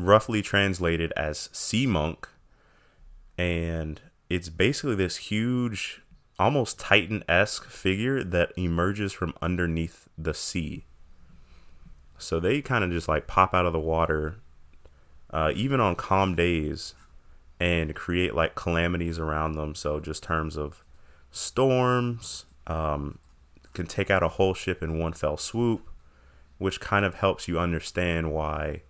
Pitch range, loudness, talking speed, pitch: 75-95 Hz, -27 LUFS, 135 wpm, 85 Hz